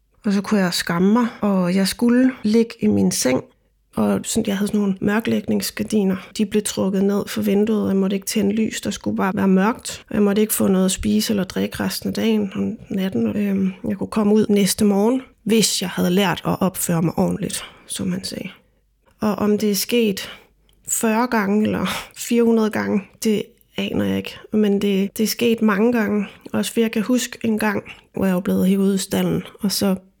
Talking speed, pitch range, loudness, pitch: 210 wpm, 195-220 Hz, -20 LUFS, 205 Hz